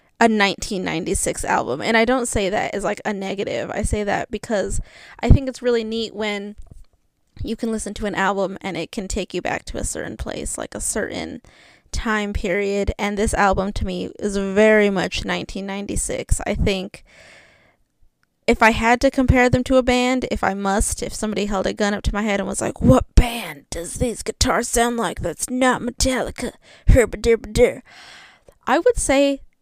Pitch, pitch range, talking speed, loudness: 215 Hz, 200-240 Hz, 185 wpm, -20 LUFS